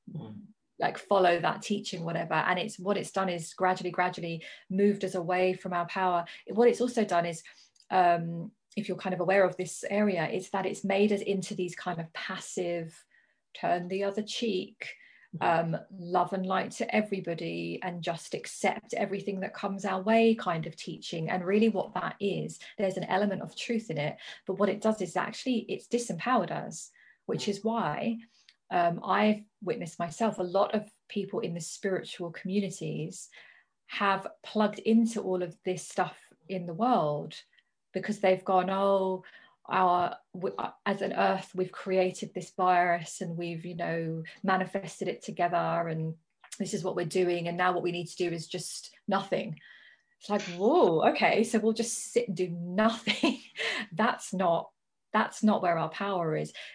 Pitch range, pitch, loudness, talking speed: 175-210 Hz, 190 Hz, -30 LUFS, 175 wpm